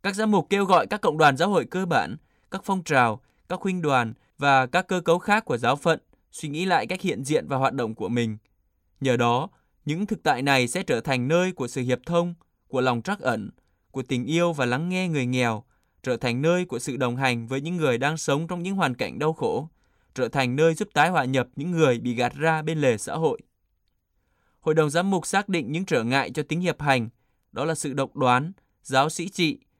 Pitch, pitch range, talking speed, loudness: 145 Hz, 125-175 Hz, 240 wpm, -24 LUFS